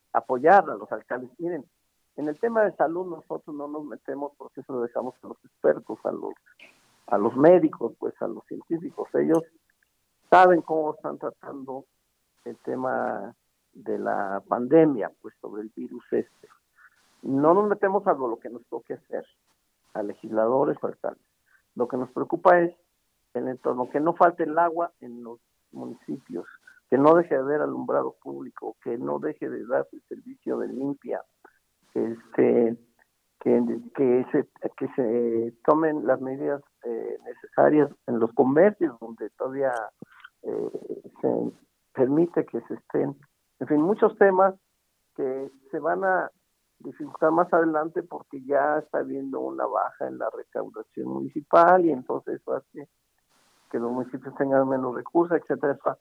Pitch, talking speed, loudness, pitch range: 155 Hz, 155 wpm, -25 LUFS, 135-190 Hz